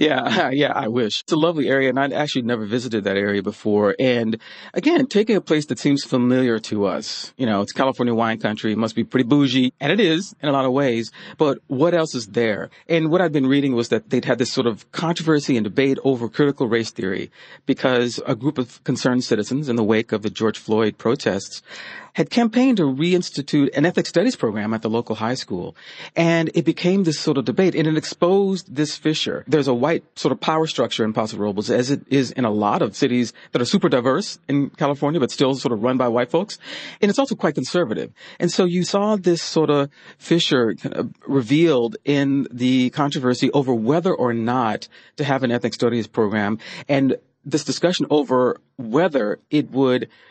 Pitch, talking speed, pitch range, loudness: 135 Hz, 205 wpm, 120-160 Hz, -20 LUFS